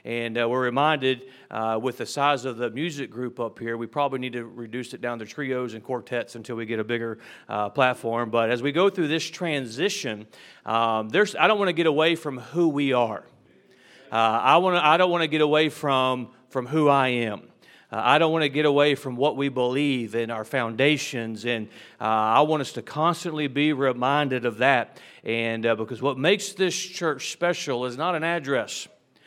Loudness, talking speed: -24 LUFS, 210 wpm